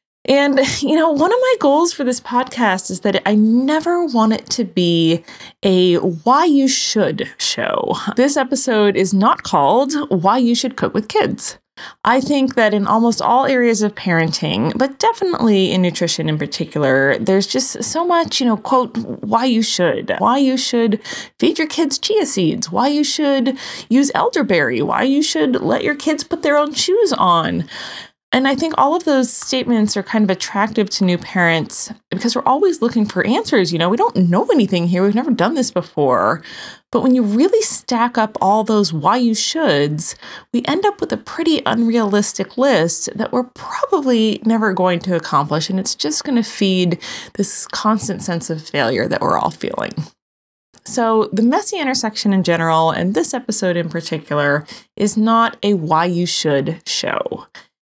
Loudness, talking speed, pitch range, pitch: -16 LUFS, 180 wpm, 185-270 Hz, 225 Hz